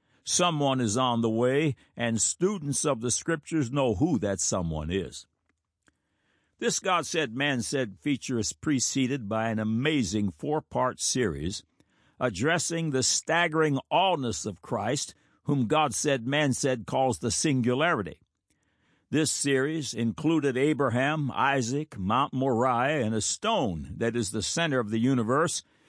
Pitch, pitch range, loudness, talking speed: 130 Hz, 115-145 Hz, -27 LUFS, 135 wpm